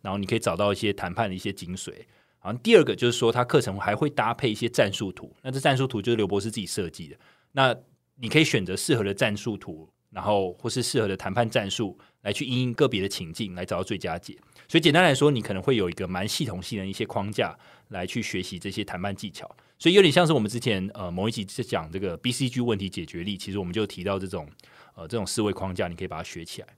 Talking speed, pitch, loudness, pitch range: 385 characters per minute, 105 Hz, -26 LUFS, 95-125 Hz